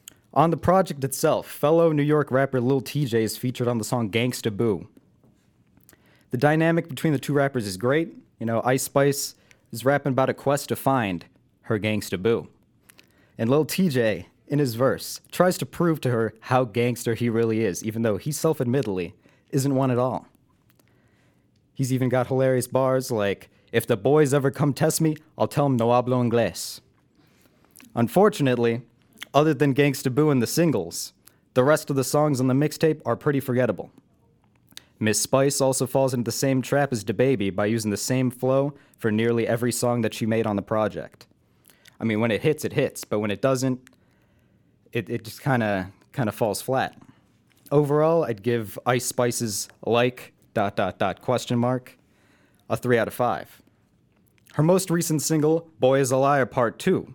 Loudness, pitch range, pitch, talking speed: -24 LUFS, 115-140 Hz, 130 Hz, 180 wpm